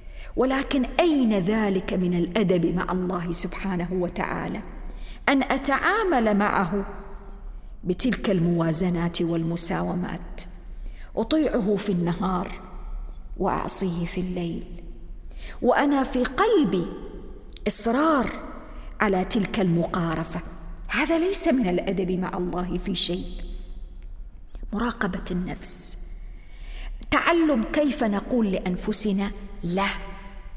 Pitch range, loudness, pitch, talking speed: 175-230 Hz, -24 LUFS, 190 Hz, 85 wpm